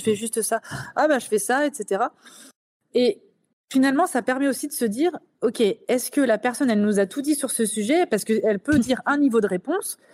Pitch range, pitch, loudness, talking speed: 220-285 Hz, 250 Hz, -22 LUFS, 230 wpm